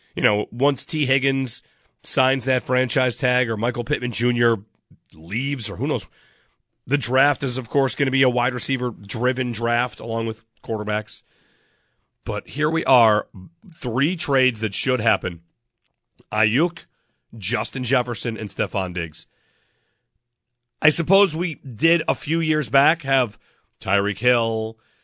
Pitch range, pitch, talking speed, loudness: 115-135 Hz, 125 Hz, 140 wpm, -21 LUFS